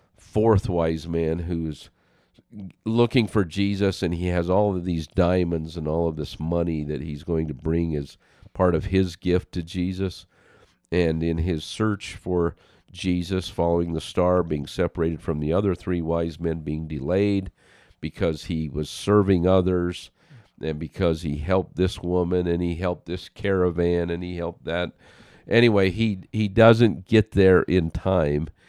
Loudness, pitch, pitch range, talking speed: -24 LUFS, 90 Hz, 80-95 Hz, 165 wpm